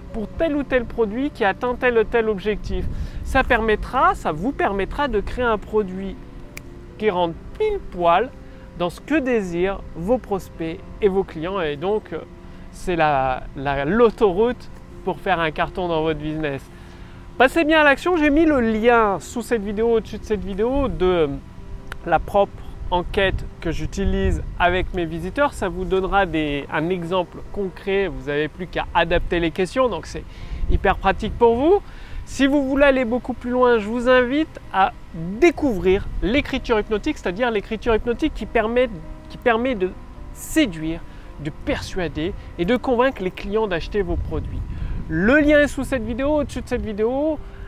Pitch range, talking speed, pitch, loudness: 170-250 Hz, 165 wpm, 210 Hz, -21 LUFS